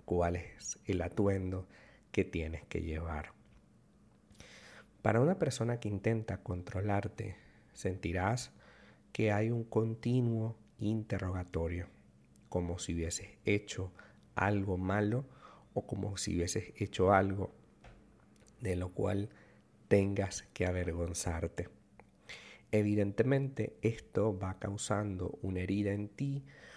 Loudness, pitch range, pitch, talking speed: -36 LUFS, 90-110 Hz, 100 Hz, 105 wpm